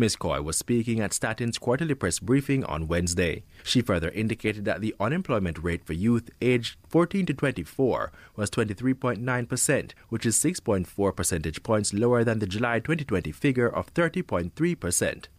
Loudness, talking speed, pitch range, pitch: -26 LUFS, 150 wpm, 95-130 Hz, 115 Hz